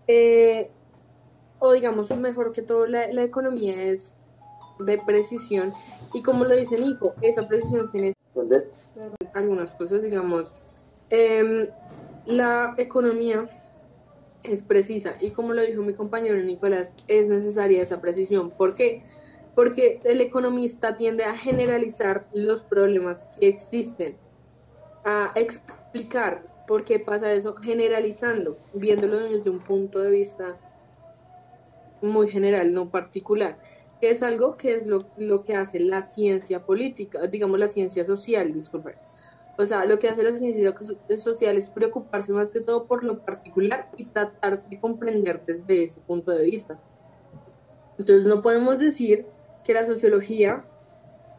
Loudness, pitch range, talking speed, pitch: -23 LUFS, 195-235 Hz, 135 wpm, 210 Hz